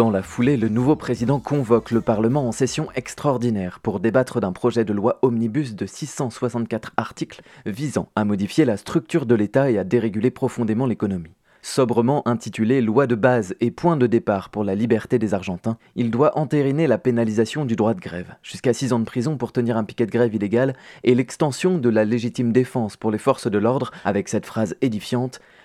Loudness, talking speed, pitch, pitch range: -21 LUFS, 195 wpm, 120 Hz, 110-130 Hz